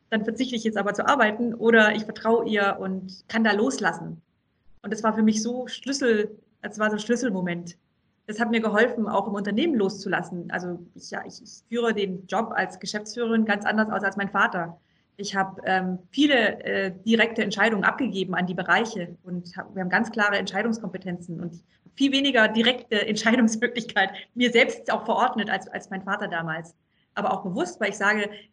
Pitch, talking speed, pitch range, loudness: 210 Hz, 185 wpm, 190-225 Hz, -24 LUFS